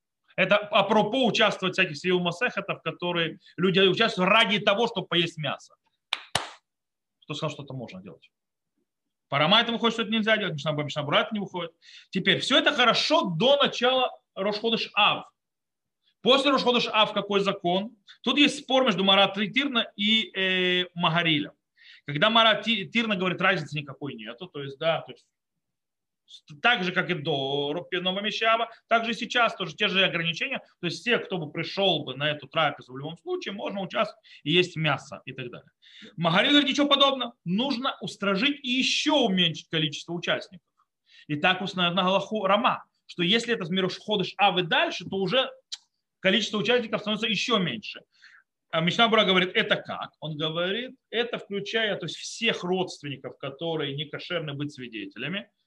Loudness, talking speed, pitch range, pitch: -24 LUFS, 160 wpm, 170-230 Hz, 195 Hz